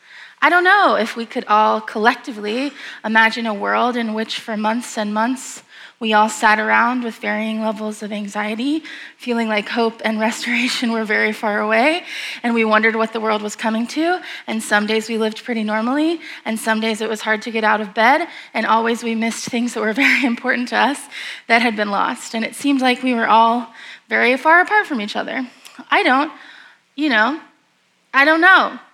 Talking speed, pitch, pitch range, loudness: 200 wpm, 230 Hz, 220-260 Hz, -17 LUFS